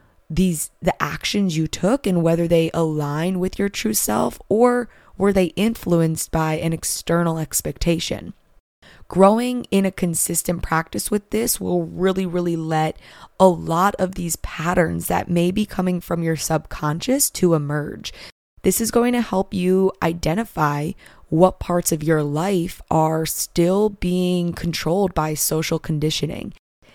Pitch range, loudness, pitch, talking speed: 160-190 Hz, -20 LUFS, 175 Hz, 145 wpm